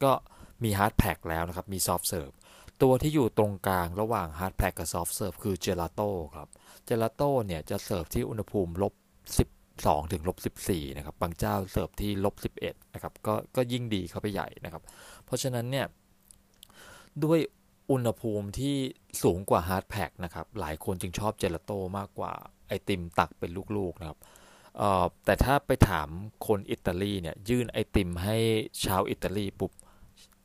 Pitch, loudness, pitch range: 100 Hz, -30 LUFS, 90-110 Hz